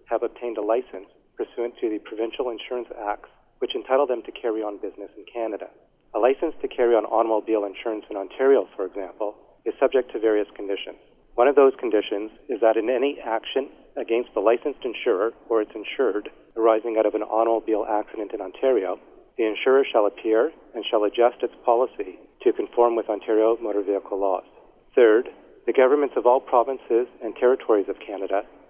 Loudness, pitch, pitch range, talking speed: -23 LUFS, 115 Hz, 105-135 Hz, 180 wpm